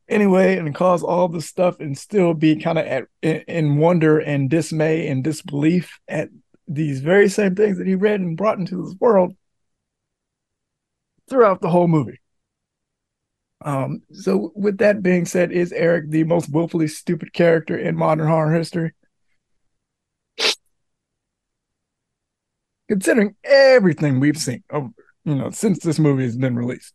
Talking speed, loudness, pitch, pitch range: 145 wpm, -19 LUFS, 165 Hz, 155-185 Hz